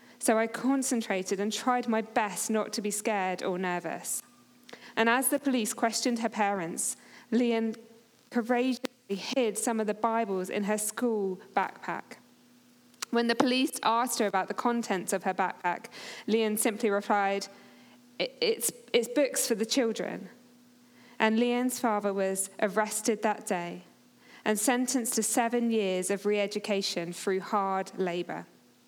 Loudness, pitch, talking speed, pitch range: -29 LUFS, 225 Hz, 145 wpm, 200-245 Hz